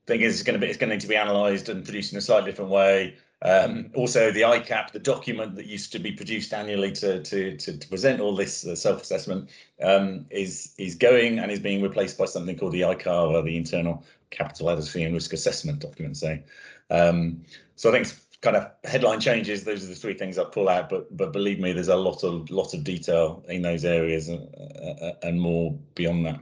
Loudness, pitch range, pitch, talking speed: -25 LUFS, 85-100 Hz, 95 Hz, 220 wpm